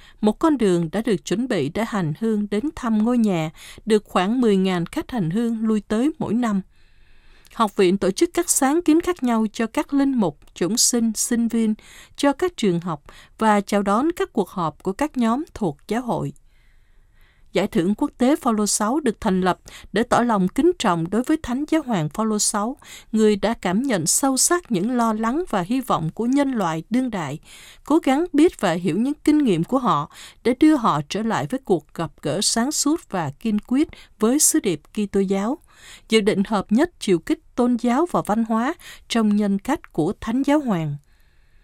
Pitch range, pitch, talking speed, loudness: 195-265 Hz, 220 Hz, 205 wpm, -21 LUFS